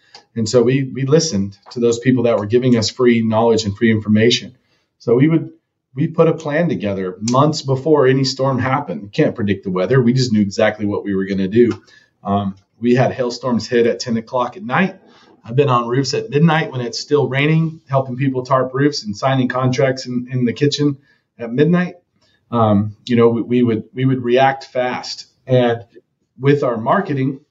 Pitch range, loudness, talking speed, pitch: 115-140 Hz, -17 LUFS, 200 wpm, 125 Hz